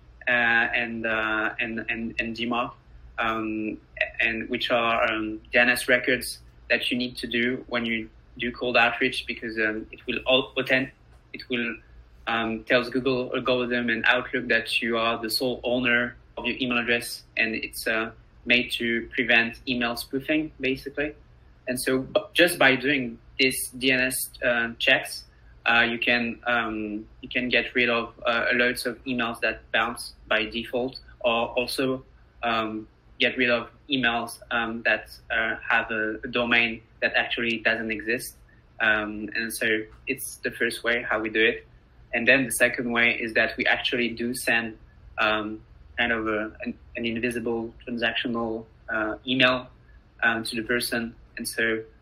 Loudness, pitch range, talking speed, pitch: -25 LUFS, 115-125 Hz, 160 wpm, 120 Hz